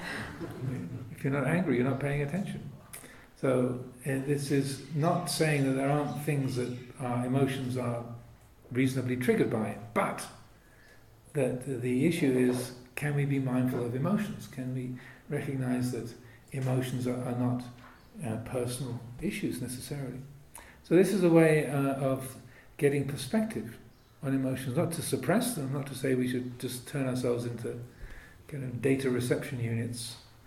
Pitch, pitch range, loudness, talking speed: 130 Hz, 125-140 Hz, -31 LUFS, 150 wpm